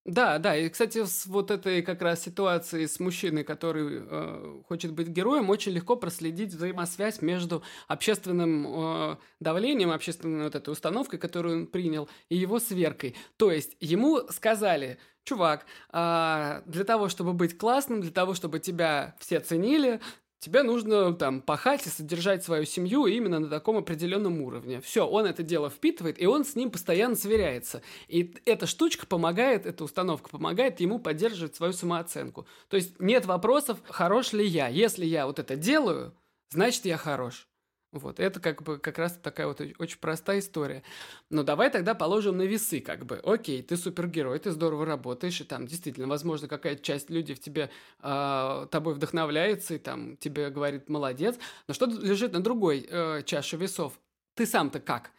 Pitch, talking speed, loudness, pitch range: 170 Hz, 165 wpm, -29 LUFS, 155-200 Hz